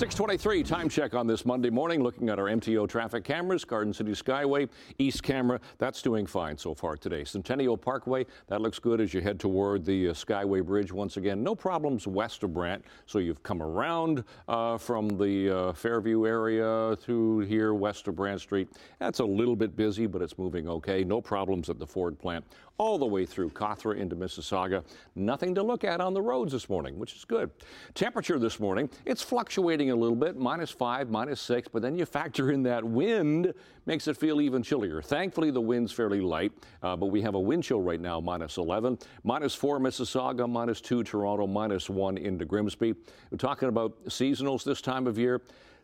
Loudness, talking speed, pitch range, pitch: -30 LUFS, 200 wpm, 100-130 Hz, 115 Hz